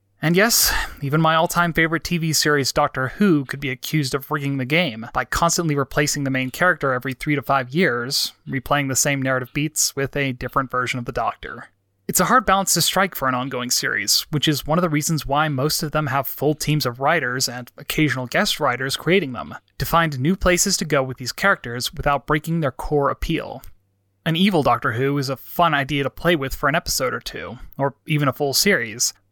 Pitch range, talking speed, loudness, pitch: 130-160 Hz, 220 wpm, -20 LUFS, 145 Hz